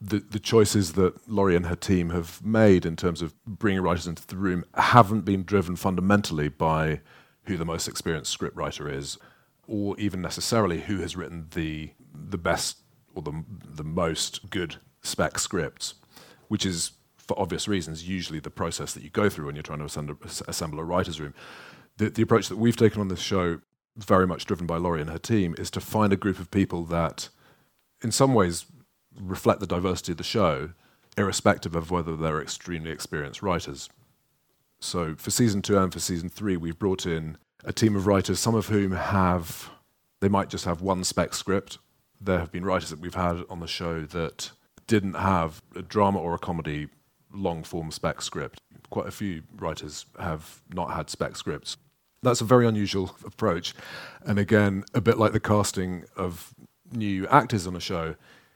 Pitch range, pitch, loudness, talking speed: 85-105 Hz, 95 Hz, -26 LUFS, 190 wpm